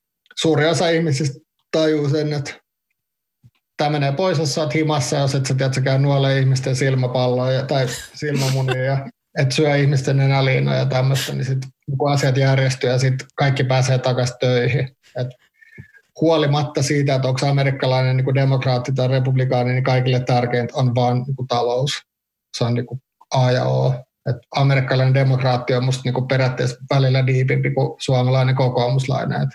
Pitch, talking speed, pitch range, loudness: 135 Hz, 160 wpm, 130-140 Hz, -19 LUFS